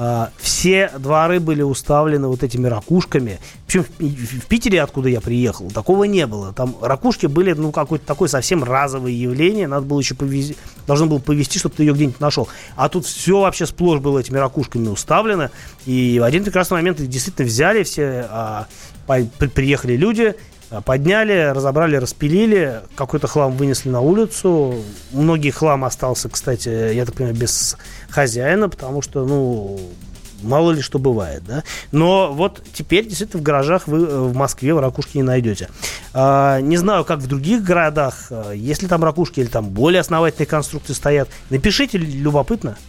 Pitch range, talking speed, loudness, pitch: 125-170 Hz, 160 wpm, -17 LUFS, 145 Hz